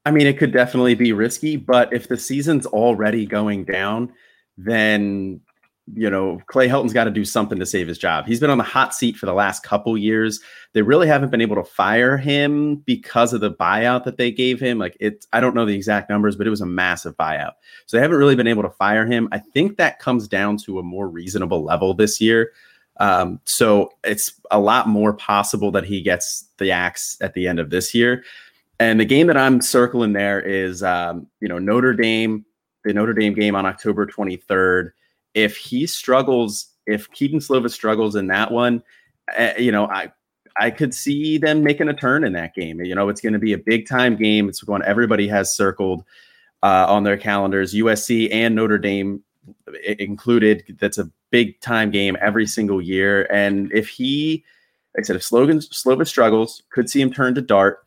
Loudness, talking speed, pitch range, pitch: -18 LUFS, 205 wpm, 100-125 Hz, 110 Hz